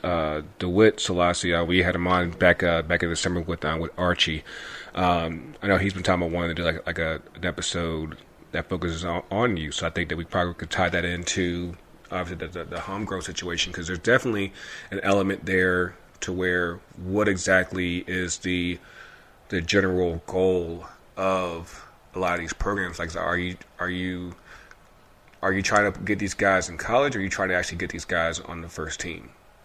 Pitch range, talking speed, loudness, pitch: 85-95 Hz, 210 wpm, -25 LUFS, 90 Hz